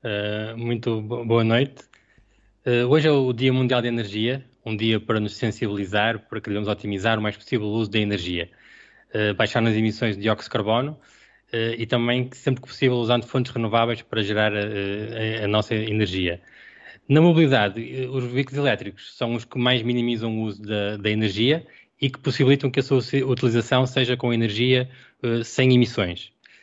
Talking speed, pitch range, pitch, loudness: 180 wpm, 105-125 Hz, 115 Hz, -23 LUFS